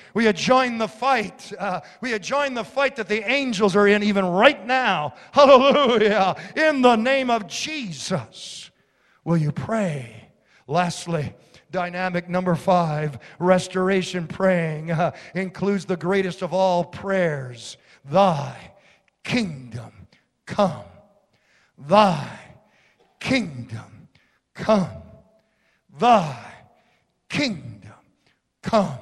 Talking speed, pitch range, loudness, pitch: 100 wpm, 170-220 Hz, -21 LUFS, 185 Hz